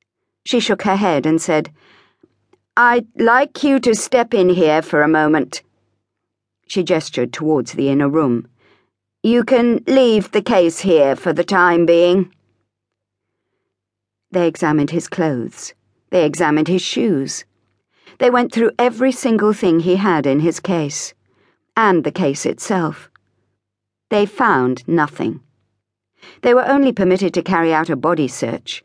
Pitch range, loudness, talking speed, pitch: 140-215 Hz, -16 LUFS, 140 wpm, 170 Hz